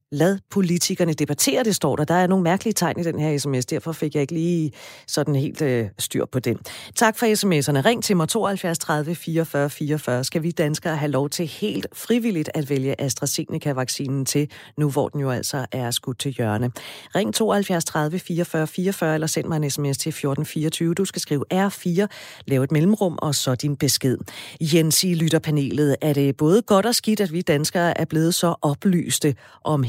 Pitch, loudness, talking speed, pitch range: 155 Hz, -22 LUFS, 195 wpm, 140-175 Hz